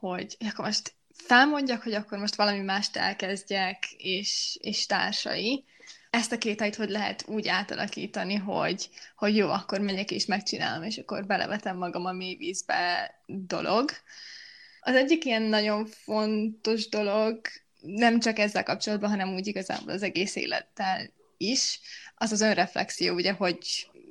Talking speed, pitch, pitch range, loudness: 145 wpm, 210 Hz, 195-225 Hz, -28 LUFS